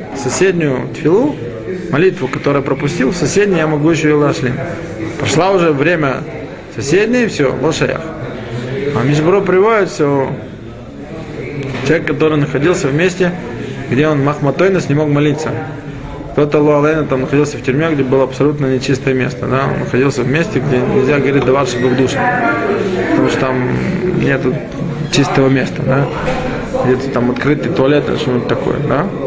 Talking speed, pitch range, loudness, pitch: 145 wpm, 135-155 Hz, -14 LUFS, 145 Hz